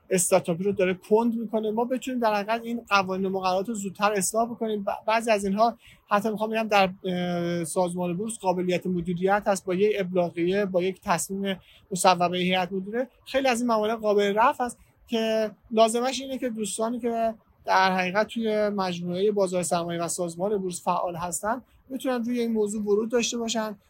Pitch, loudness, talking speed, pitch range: 205 Hz, -26 LUFS, 175 wpm, 185-225 Hz